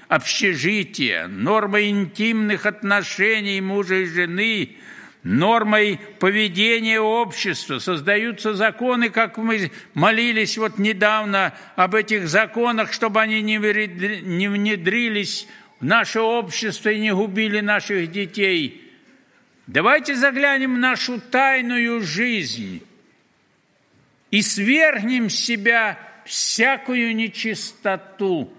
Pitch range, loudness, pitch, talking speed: 200-230 Hz, -19 LUFS, 215 Hz, 95 wpm